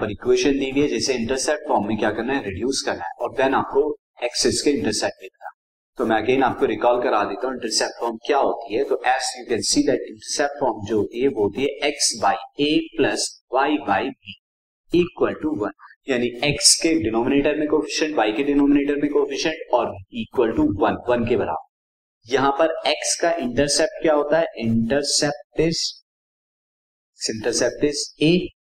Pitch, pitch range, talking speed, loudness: 145 Hz, 125-160 Hz, 65 wpm, -21 LUFS